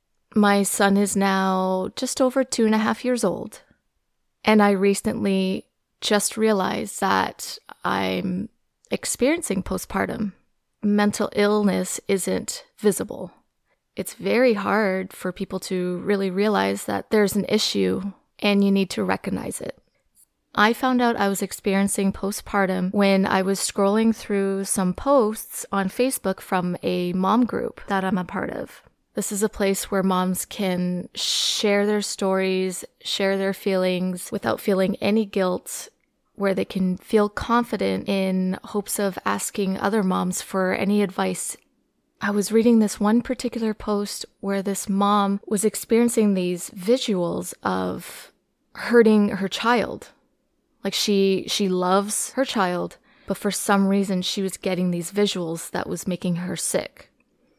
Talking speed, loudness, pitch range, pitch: 145 wpm, -23 LUFS, 190-215 Hz, 200 Hz